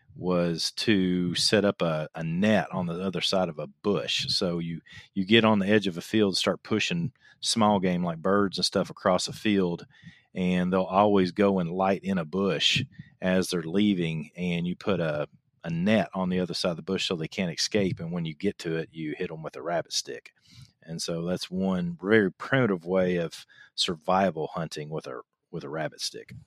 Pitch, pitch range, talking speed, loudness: 90 Hz, 85-100 Hz, 210 wpm, -27 LUFS